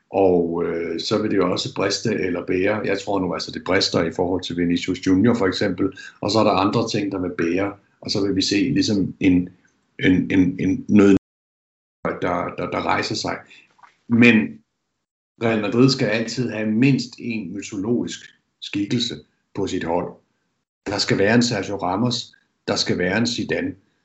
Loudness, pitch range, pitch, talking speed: -21 LUFS, 90-115 Hz, 100 Hz, 180 wpm